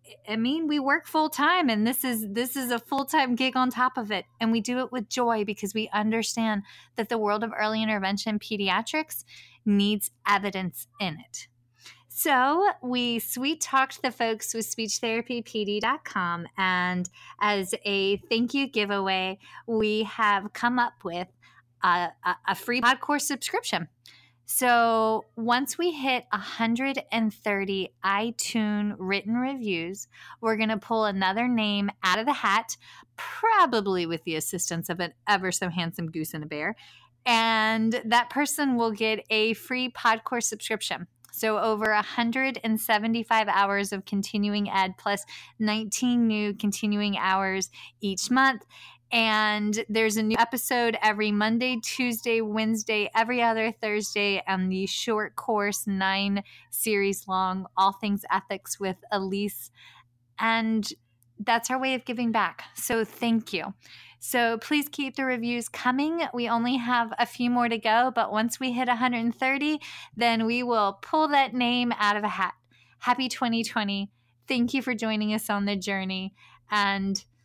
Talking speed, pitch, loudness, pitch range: 145 wpm, 220 Hz, -26 LUFS, 200-240 Hz